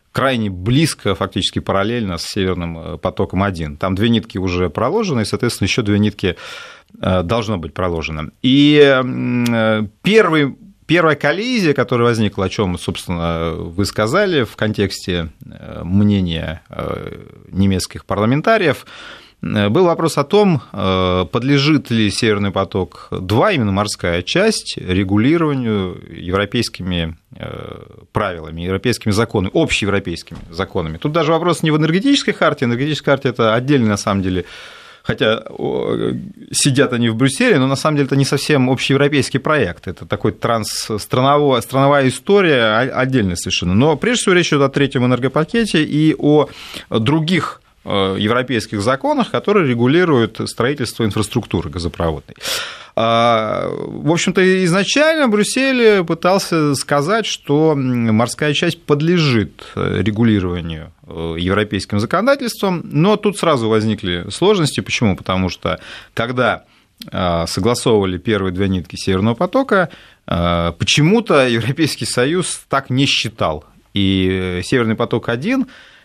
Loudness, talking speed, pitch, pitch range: -16 LUFS, 115 wpm, 115 Hz, 95-150 Hz